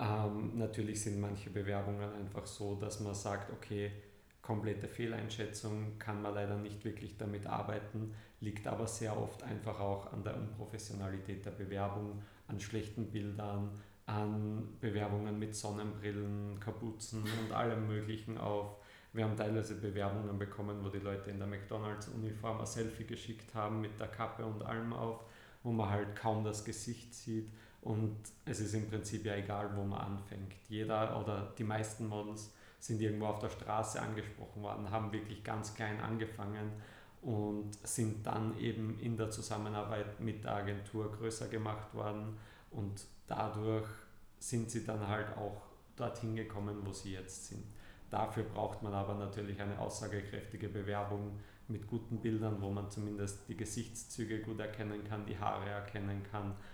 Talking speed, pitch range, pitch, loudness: 155 wpm, 100-110 Hz, 105 Hz, -41 LUFS